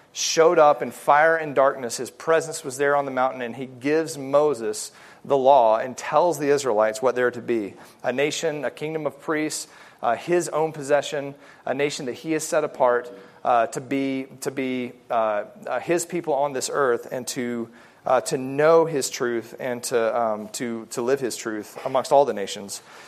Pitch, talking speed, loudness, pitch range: 135 Hz, 190 wpm, -23 LUFS, 120-150 Hz